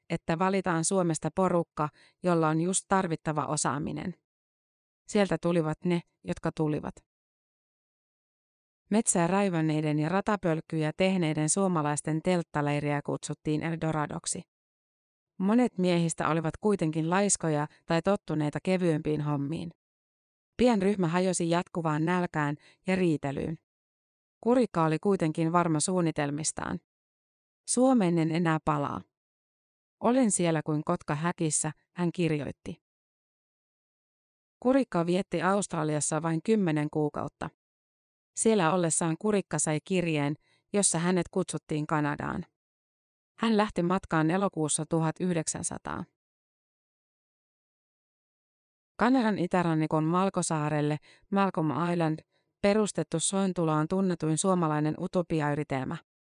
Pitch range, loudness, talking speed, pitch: 155-185 Hz, -28 LUFS, 90 wpm, 165 Hz